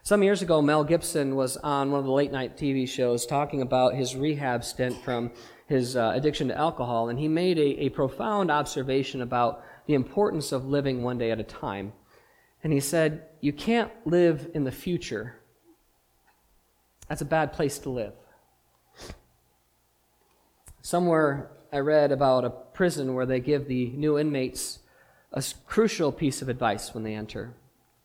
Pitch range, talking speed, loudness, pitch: 125-150 Hz, 165 wpm, -27 LUFS, 140 Hz